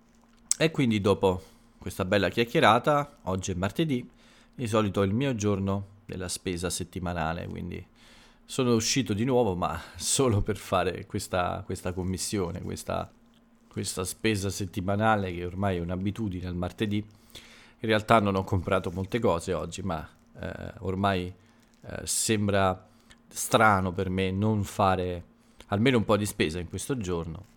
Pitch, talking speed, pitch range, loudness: 100 Hz, 145 wpm, 95-115 Hz, -28 LUFS